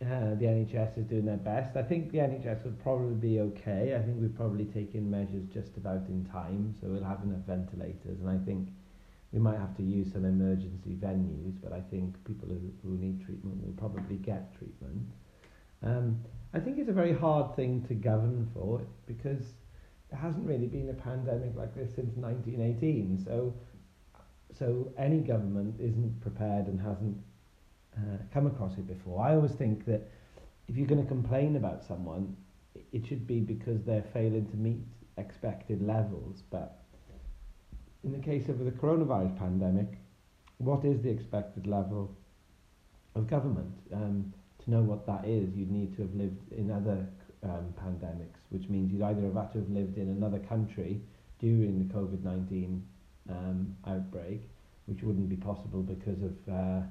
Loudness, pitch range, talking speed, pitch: -34 LUFS, 95-115 Hz, 175 wpm, 100 Hz